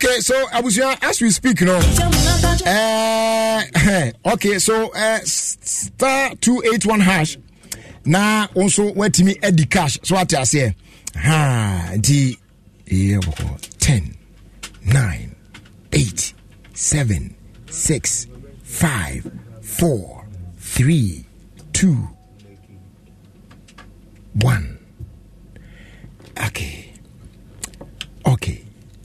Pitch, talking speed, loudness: 135 Hz, 90 wpm, -17 LUFS